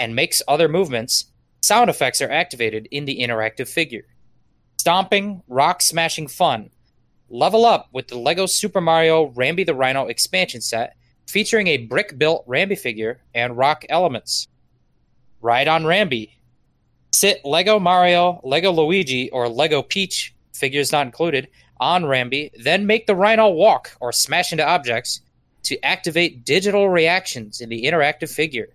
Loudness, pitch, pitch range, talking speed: -18 LUFS, 155 Hz, 125-185 Hz, 145 wpm